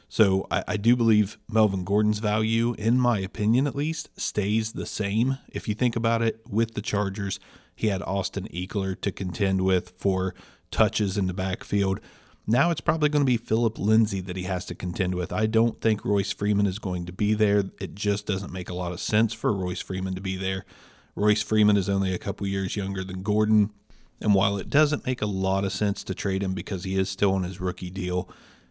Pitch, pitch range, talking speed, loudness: 100 Hz, 95-110 Hz, 215 wpm, -26 LUFS